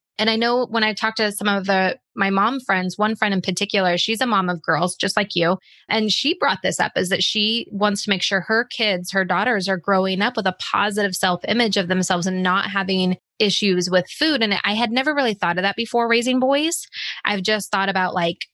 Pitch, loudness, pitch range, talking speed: 200 Hz, -20 LUFS, 190-220 Hz, 235 wpm